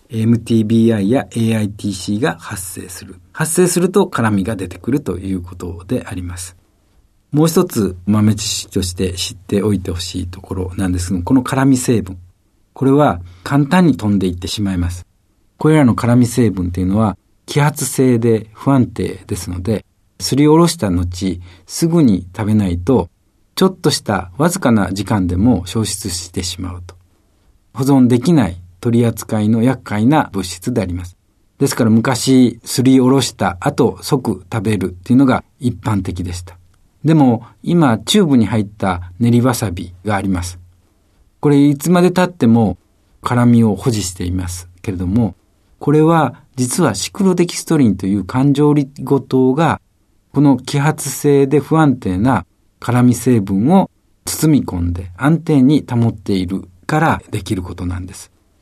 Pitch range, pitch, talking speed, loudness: 95-130 Hz, 105 Hz, 310 characters per minute, -15 LUFS